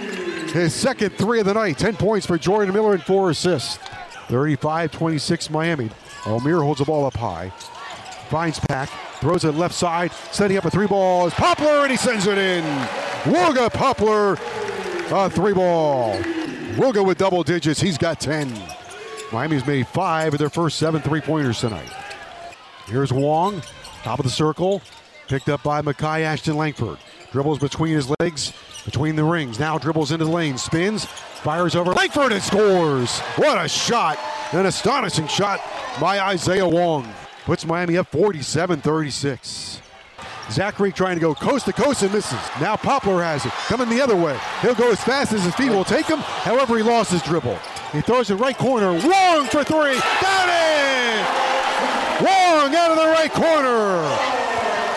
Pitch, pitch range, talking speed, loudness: 175 Hz, 150-215 Hz, 170 wpm, -20 LUFS